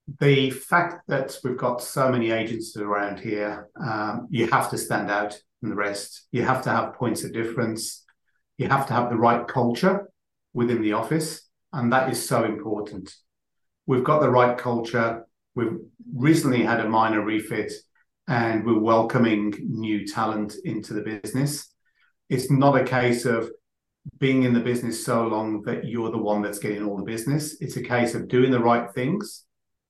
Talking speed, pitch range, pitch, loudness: 175 wpm, 110-130 Hz, 120 Hz, -24 LUFS